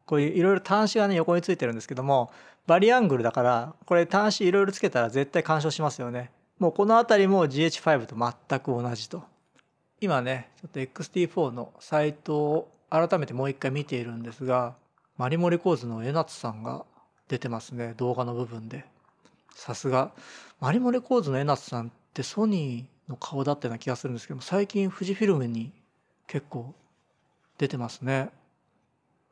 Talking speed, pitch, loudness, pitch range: 350 characters per minute, 140 Hz, -27 LUFS, 125-175 Hz